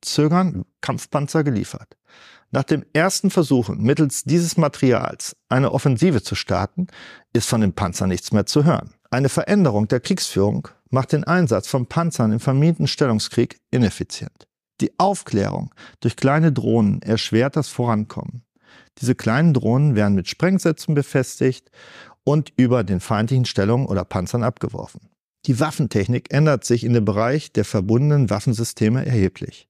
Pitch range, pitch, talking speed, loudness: 110-150 Hz, 130 Hz, 140 wpm, -20 LUFS